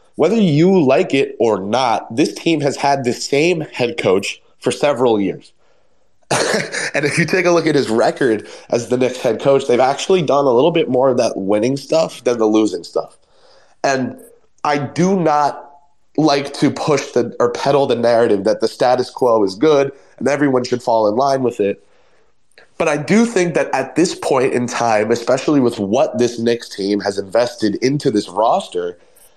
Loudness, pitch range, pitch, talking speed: -16 LUFS, 120-160 Hz, 140 Hz, 190 wpm